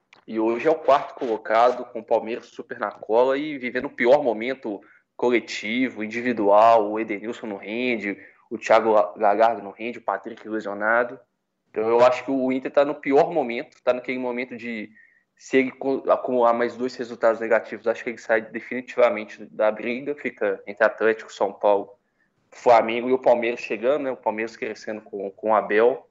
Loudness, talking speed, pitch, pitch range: -23 LUFS, 175 wpm, 120 Hz, 110-130 Hz